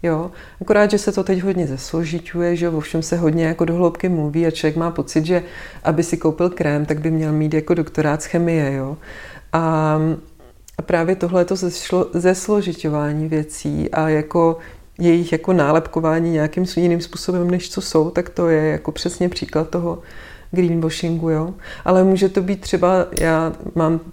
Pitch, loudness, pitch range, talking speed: 165 Hz, -19 LUFS, 155-180 Hz, 170 wpm